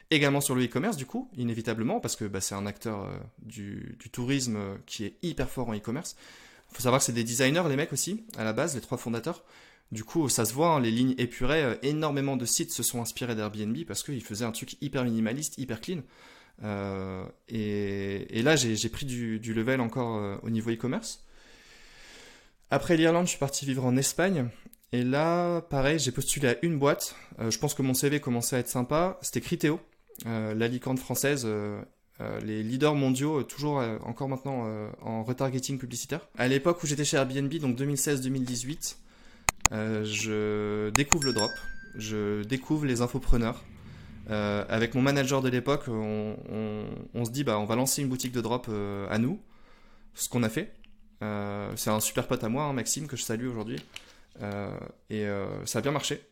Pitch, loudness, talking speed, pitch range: 125 Hz, -29 LUFS, 200 wpm, 110-140 Hz